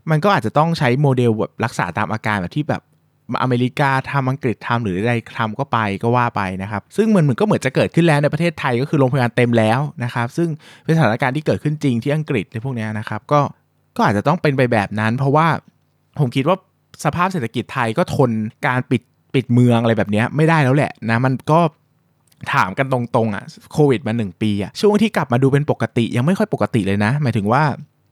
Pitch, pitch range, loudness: 130 Hz, 110-150 Hz, -18 LUFS